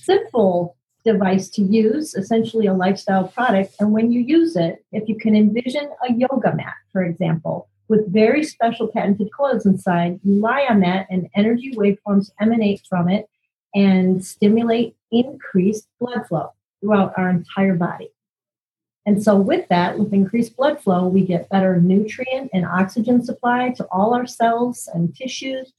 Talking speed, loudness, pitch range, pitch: 160 wpm, -19 LUFS, 190-235 Hz, 210 Hz